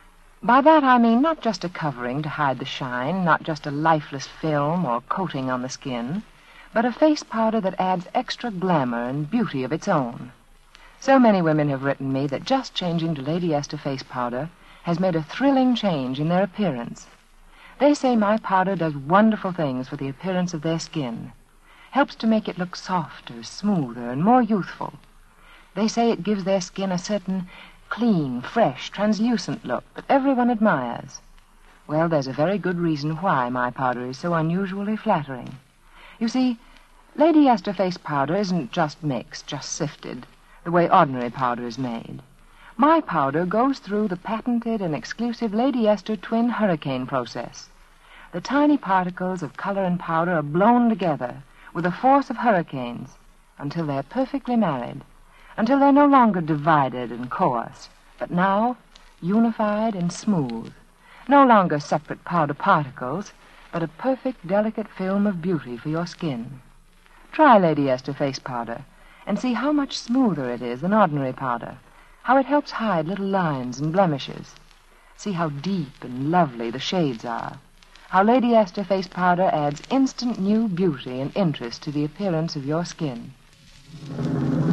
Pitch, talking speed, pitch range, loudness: 180 Hz, 165 wpm, 145-220 Hz, -22 LUFS